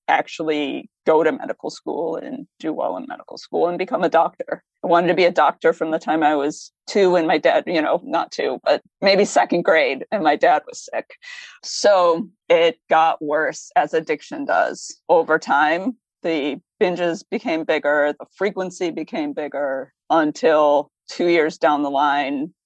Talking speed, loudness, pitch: 175 wpm, -20 LUFS, 175 Hz